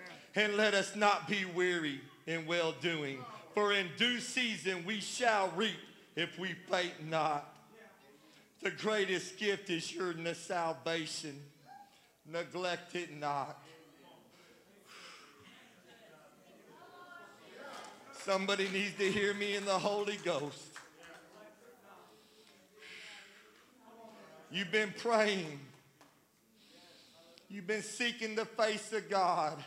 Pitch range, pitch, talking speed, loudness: 165-215 Hz, 190 Hz, 95 wpm, -35 LUFS